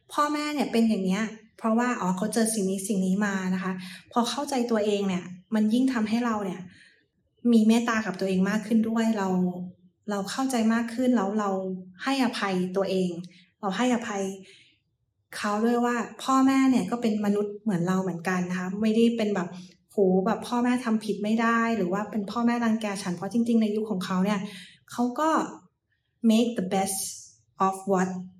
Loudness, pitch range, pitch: -26 LUFS, 185-230 Hz, 205 Hz